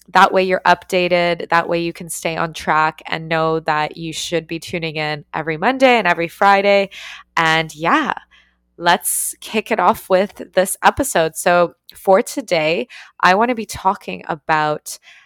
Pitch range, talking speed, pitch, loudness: 160-190 Hz, 165 wpm, 175 Hz, -17 LUFS